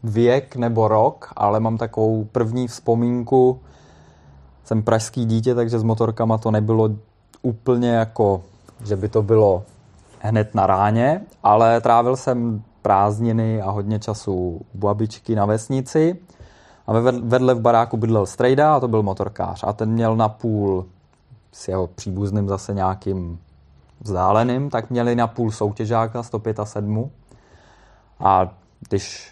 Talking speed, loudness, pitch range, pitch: 135 wpm, -20 LUFS, 100-120 Hz, 110 Hz